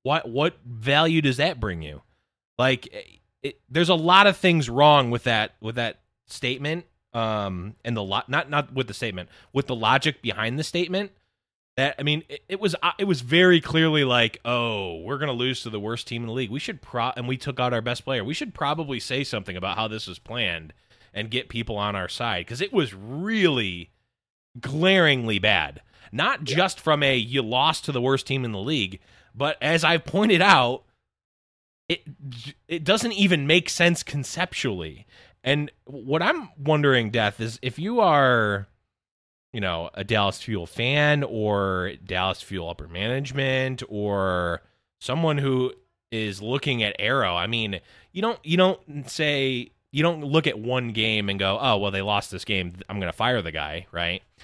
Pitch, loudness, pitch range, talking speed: 125 Hz, -23 LUFS, 105-150 Hz, 185 wpm